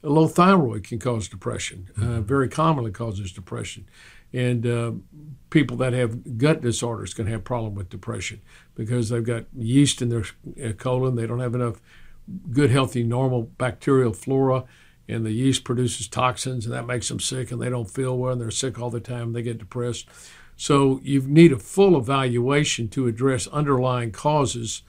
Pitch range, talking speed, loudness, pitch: 115-135 Hz, 180 wpm, -23 LUFS, 125 Hz